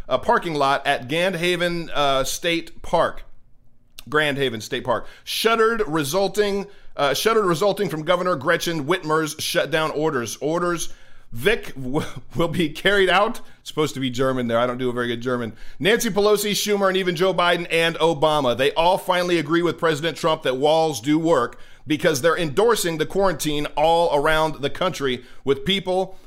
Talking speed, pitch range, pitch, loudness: 170 wpm, 140-185 Hz, 165 Hz, -21 LUFS